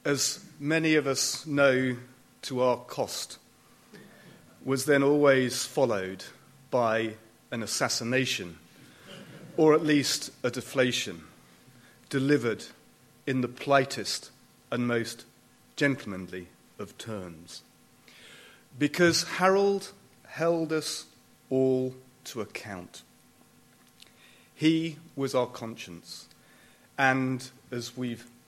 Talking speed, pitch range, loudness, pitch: 90 wpm, 120-145 Hz, -28 LUFS, 130 Hz